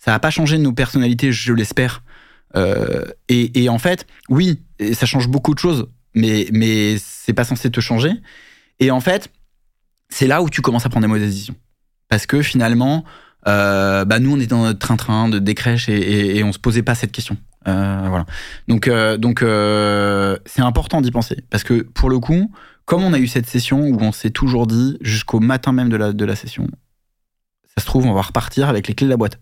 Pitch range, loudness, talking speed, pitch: 105-130 Hz, -17 LUFS, 220 wpm, 120 Hz